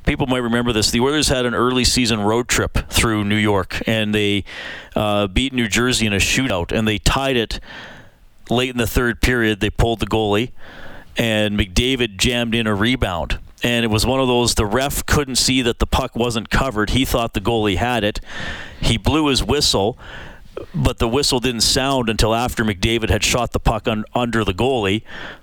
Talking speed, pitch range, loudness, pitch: 200 wpm, 105-125 Hz, -18 LUFS, 115 Hz